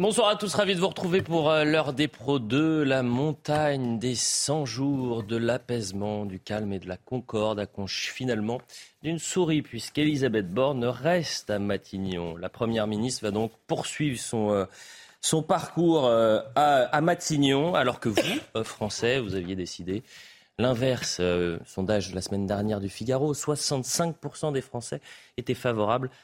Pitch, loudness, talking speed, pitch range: 125 Hz, -27 LUFS, 160 wpm, 105-150 Hz